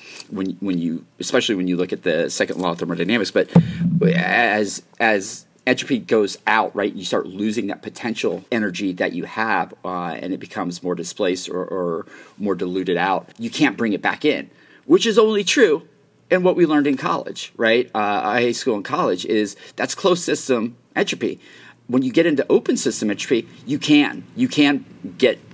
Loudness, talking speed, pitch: -20 LUFS, 190 wpm, 165 Hz